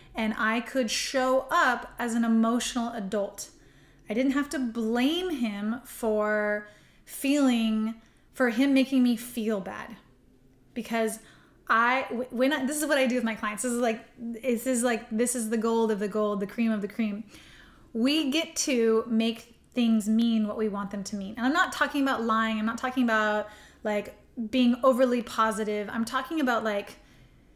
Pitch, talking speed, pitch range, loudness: 230 Hz, 180 wpm, 220-255 Hz, -27 LUFS